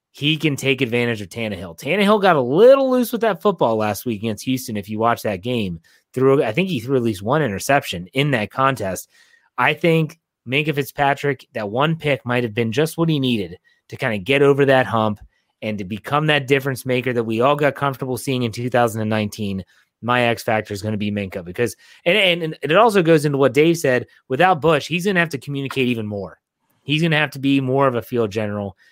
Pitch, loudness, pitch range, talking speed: 130 Hz, -19 LUFS, 110-150 Hz, 230 wpm